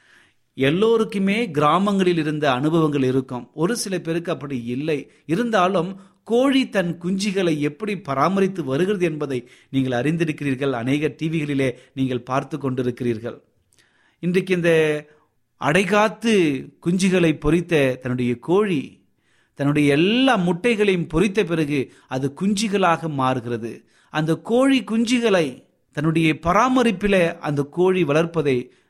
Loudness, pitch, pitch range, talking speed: -21 LUFS, 160 Hz, 140-190 Hz, 100 wpm